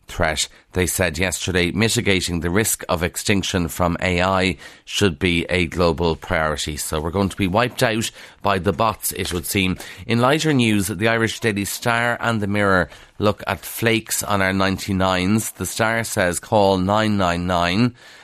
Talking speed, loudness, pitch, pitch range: 165 wpm, -20 LUFS, 95 Hz, 90-110 Hz